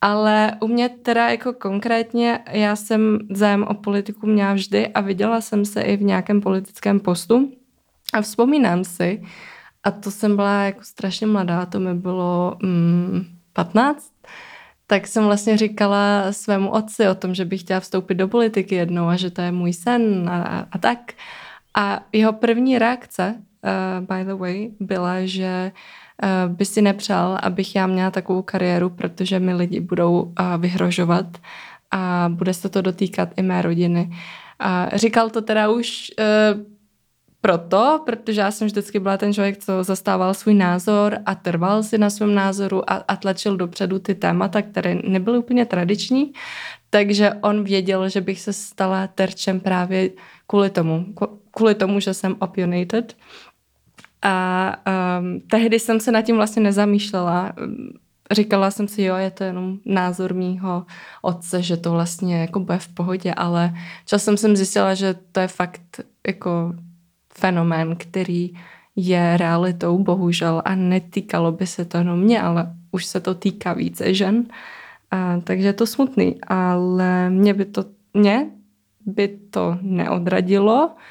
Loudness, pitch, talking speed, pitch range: -20 LUFS, 195 Hz, 155 wpm, 180-210 Hz